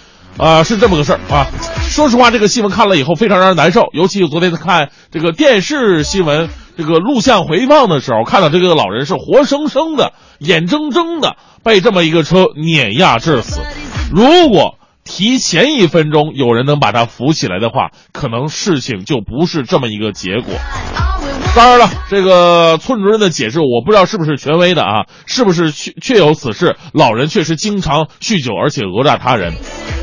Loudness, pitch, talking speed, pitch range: -11 LUFS, 175 Hz, 290 characters per minute, 150-215 Hz